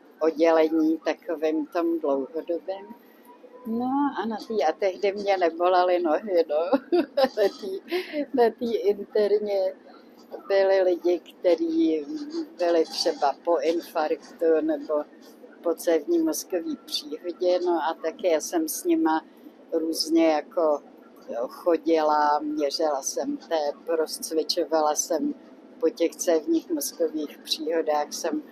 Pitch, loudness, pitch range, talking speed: 175 Hz, -25 LUFS, 160-265 Hz, 110 wpm